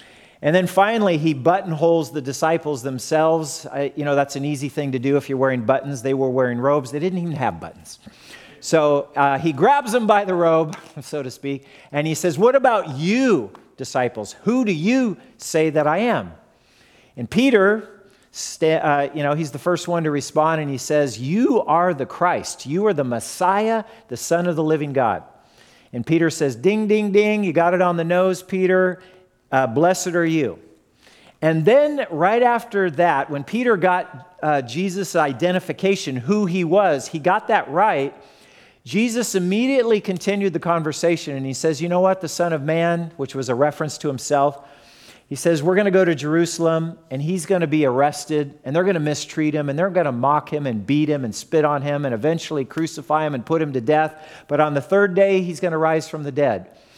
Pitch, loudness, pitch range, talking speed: 160 Hz, -20 LUFS, 145-185 Hz, 205 wpm